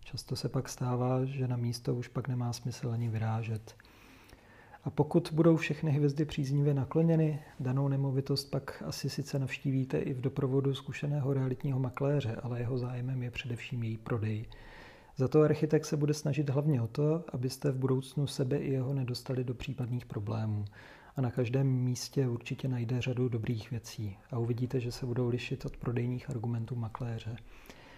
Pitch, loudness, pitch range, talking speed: 130 Hz, -33 LUFS, 120-140 Hz, 165 wpm